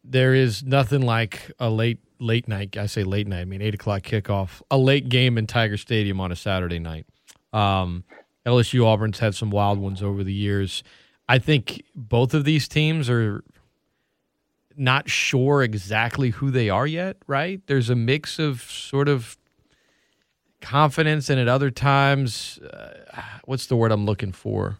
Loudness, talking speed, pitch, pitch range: -22 LUFS, 170 wpm, 120 Hz, 105-135 Hz